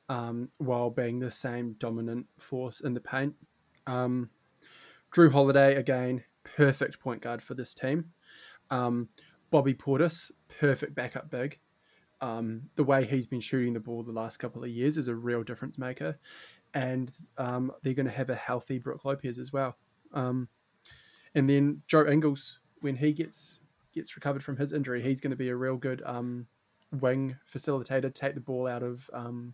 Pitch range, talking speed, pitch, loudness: 120-140 Hz, 175 wpm, 130 Hz, -31 LUFS